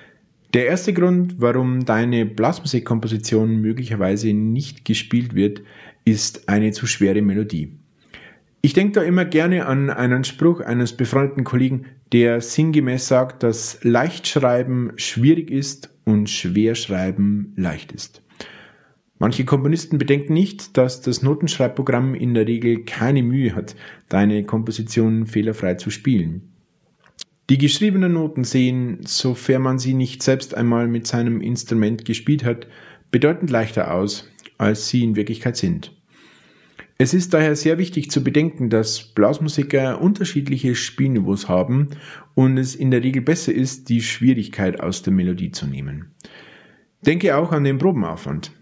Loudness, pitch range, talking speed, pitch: -19 LUFS, 110-145 Hz, 135 wpm, 125 Hz